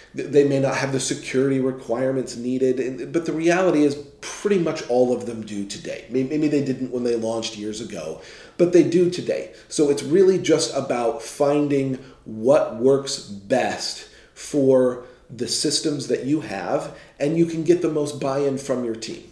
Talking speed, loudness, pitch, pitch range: 175 wpm, -22 LUFS, 135 Hz, 125-150 Hz